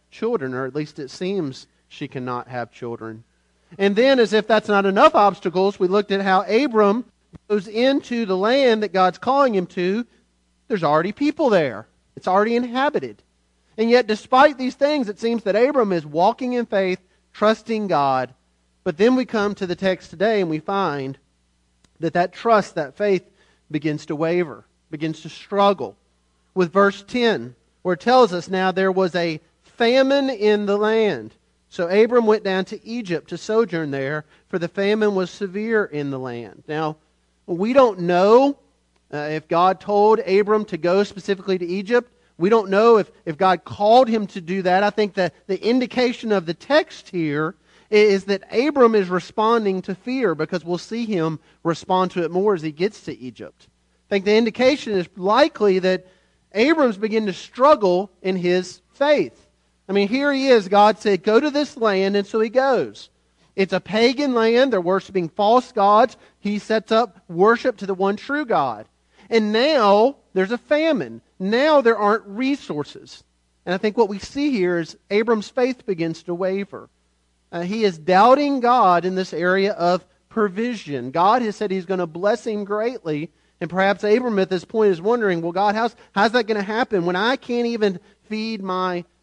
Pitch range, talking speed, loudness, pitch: 175-225 Hz, 180 wpm, -20 LUFS, 200 Hz